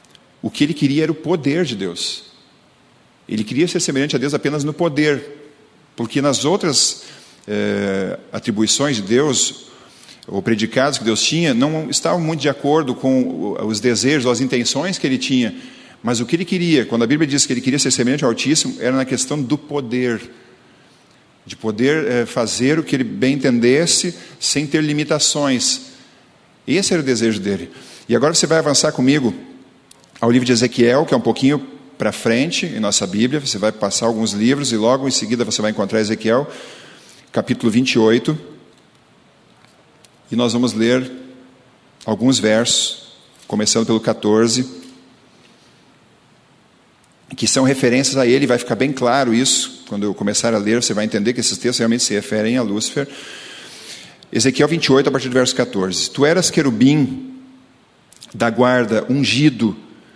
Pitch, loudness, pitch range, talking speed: 130 Hz, -17 LUFS, 115-145 Hz, 165 wpm